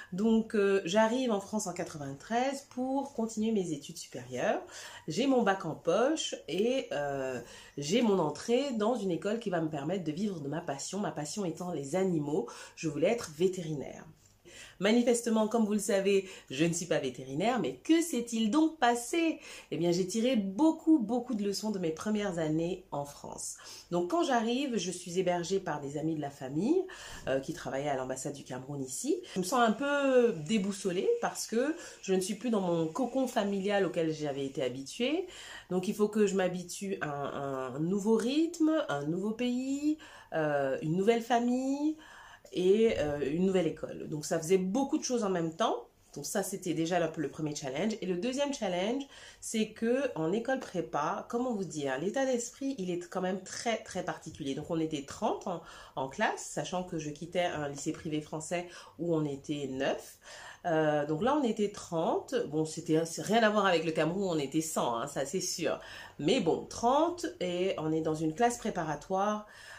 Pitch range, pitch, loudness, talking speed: 160-235 Hz, 190 Hz, -32 LUFS, 195 wpm